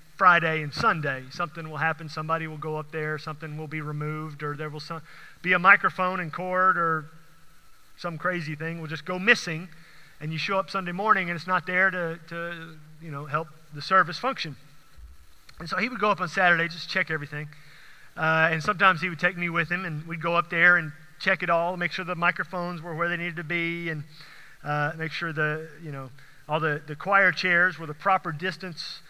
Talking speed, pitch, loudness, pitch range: 215 wpm, 165 Hz, -25 LUFS, 155-180 Hz